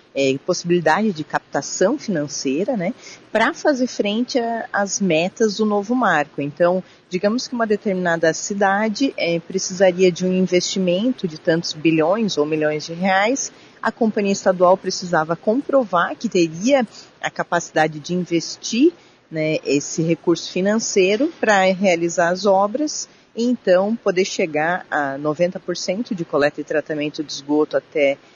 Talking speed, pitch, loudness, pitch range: 135 wpm, 185 Hz, -20 LUFS, 160-215 Hz